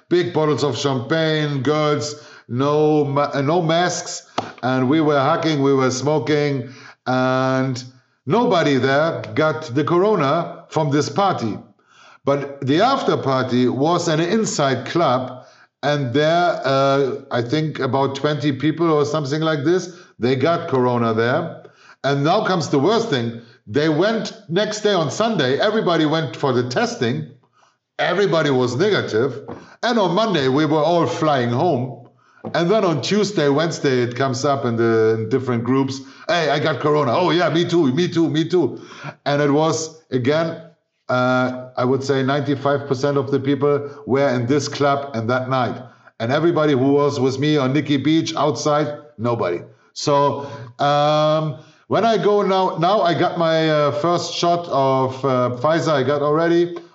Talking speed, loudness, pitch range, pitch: 160 wpm, -19 LUFS, 135-160 Hz, 145 Hz